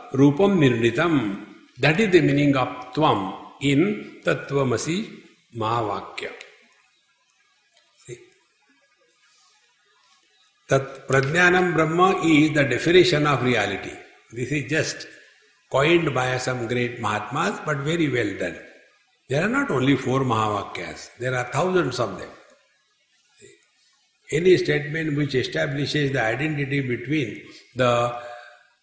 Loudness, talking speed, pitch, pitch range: -22 LUFS, 85 wpm, 140 Hz, 125-160 Hz